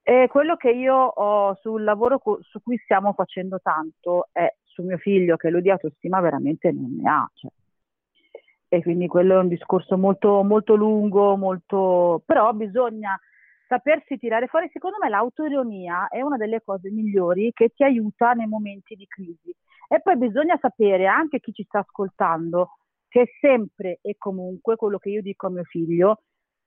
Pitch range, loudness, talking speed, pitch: 185-250 Hz, -21 LUFS, 170 wpm, 210 Hz